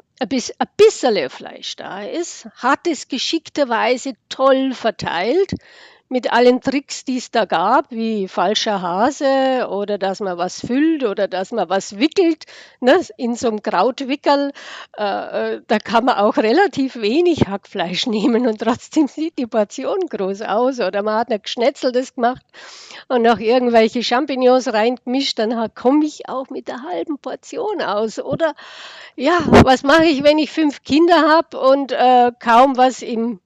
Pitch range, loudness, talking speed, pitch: 225-290 Hz, -17 LUFS, 155 wpm, 255 Hz